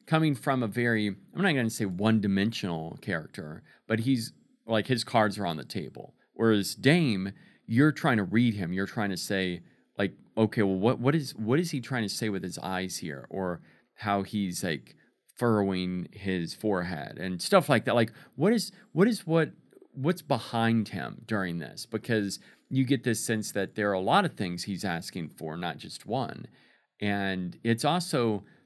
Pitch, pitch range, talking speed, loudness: 110 Hz, 95-135 Hz, 190 wpm, -29 LUFS